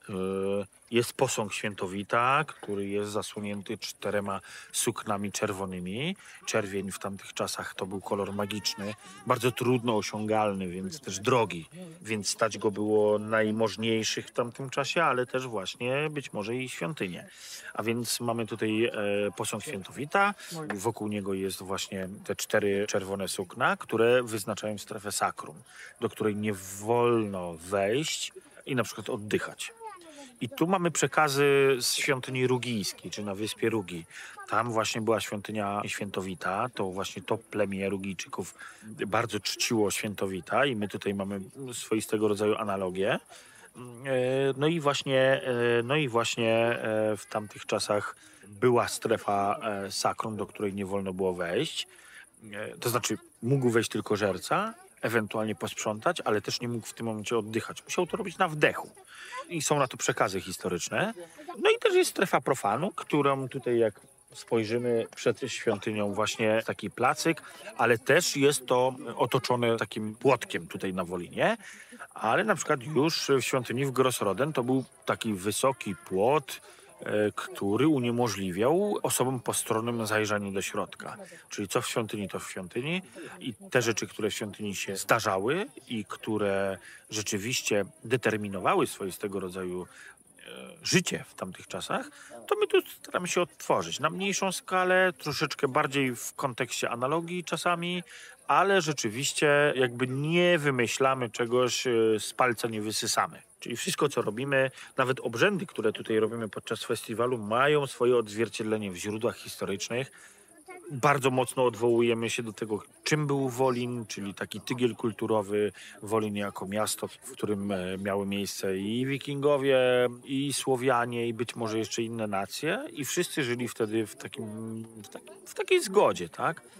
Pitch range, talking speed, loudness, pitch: 105-135 Hz, 140 wpm, -29 LUFS, 115 Hz